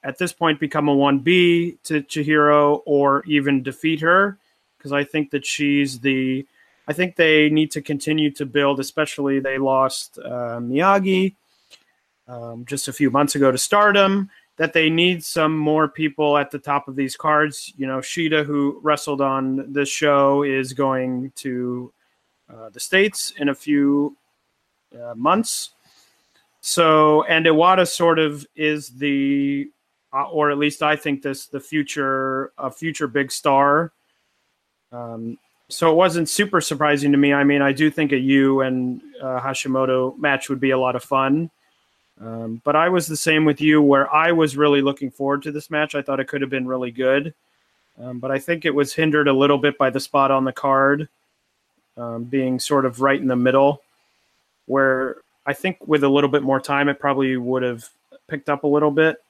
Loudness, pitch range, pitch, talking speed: -19 LUFS, 135-155 Hz, 145 Hz, 185 wpm